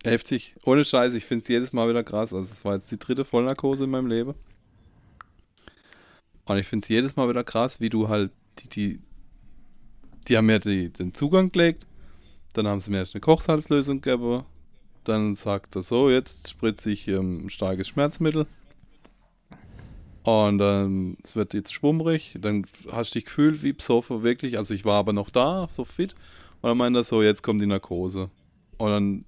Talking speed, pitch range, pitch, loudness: 190 wpm, 100-130 Hz, 110 Hz, -25 LUFS